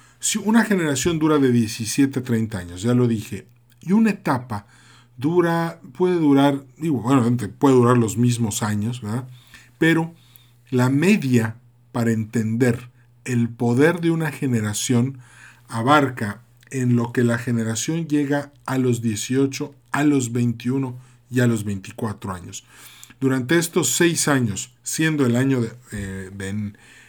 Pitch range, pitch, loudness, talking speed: 115-140 Hz, 125 Hz, -21 LUFS, 140 wpm